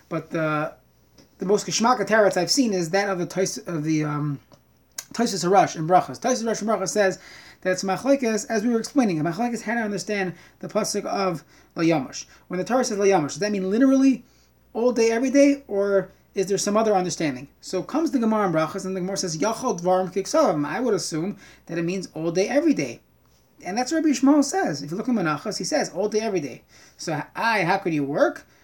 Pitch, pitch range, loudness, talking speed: 195 Hz, 180-230 Hz, -23 LUFS, 205 wpm